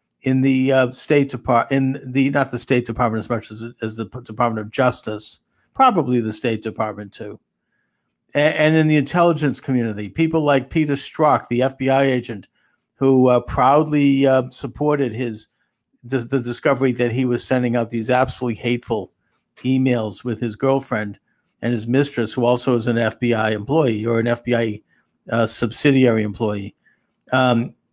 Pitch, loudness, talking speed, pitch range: 125 Hz, -19 LUFS, 155 wpm, 115-135 Hz